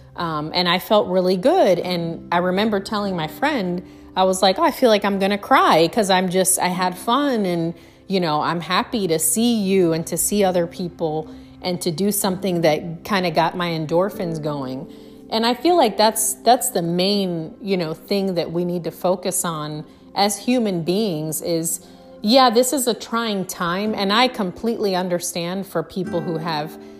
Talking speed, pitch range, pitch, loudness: 195 wpm, 165-210 Hz, 185 Hz, -20 LUFS